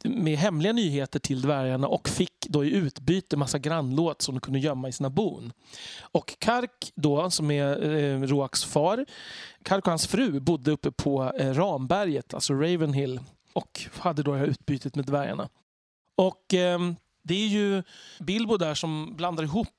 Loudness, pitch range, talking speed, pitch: -27 LUFS, 140-185 Hz, 170 wpm, 155 Hz